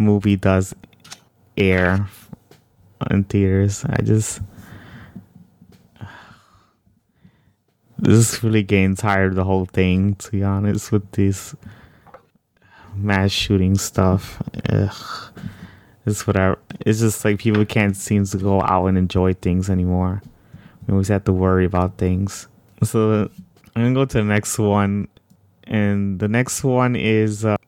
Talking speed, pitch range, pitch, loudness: 130 wpm, 95-110 Hz, 100 Hz, -19 LUFS